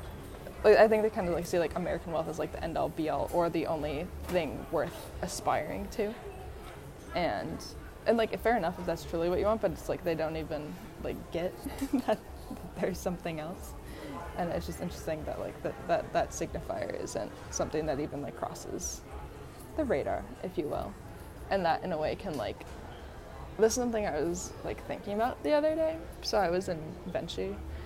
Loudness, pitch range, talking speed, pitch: -32 LUFS, 165-220 Hz, 200 wpm, 200 Hz